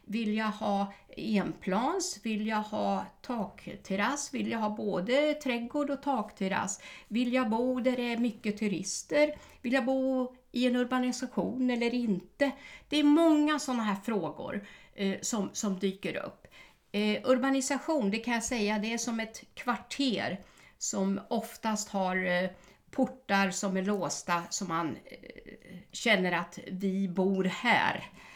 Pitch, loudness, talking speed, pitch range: 220 Hz, -31 LUFS, 140 wpm, 195-255 Hz